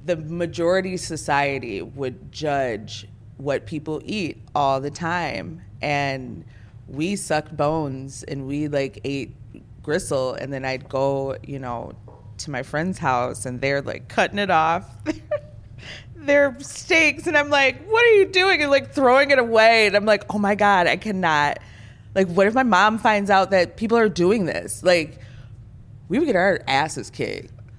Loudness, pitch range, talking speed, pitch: -21 LUFS, 130-205 Hz, 165 wpm, 155 Hz